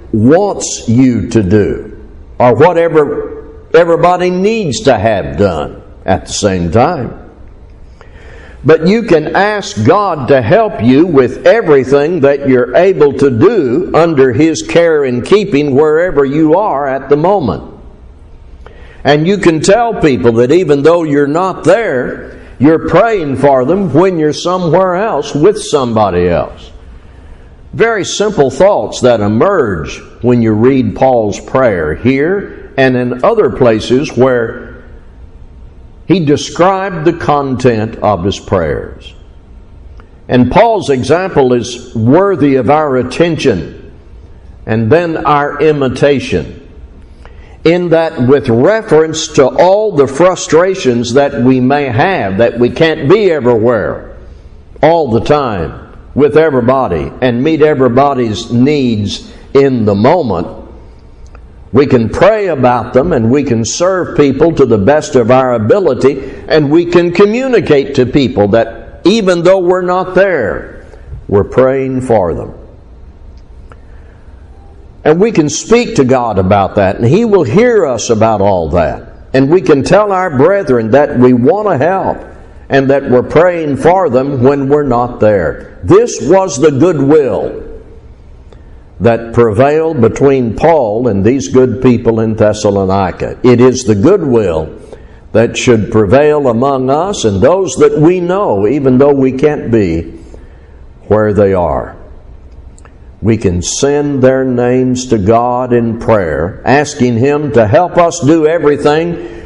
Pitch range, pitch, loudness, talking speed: 105-155 Hz, 130 Hz, -10 LUFS, 135 wpm